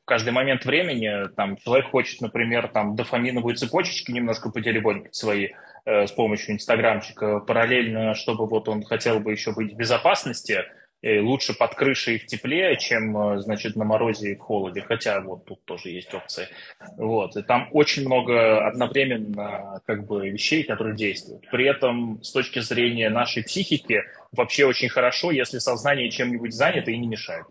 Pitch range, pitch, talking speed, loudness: 105-125 Hz, 115 Hz, 165 wpm, -23 LUFS